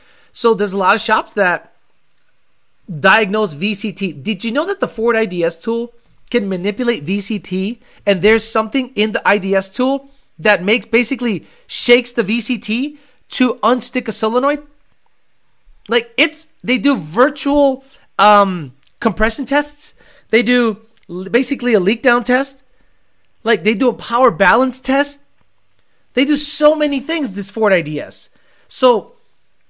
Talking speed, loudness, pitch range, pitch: 135 wpm, -15 LUFS, 210-260 Hz, 235 Hz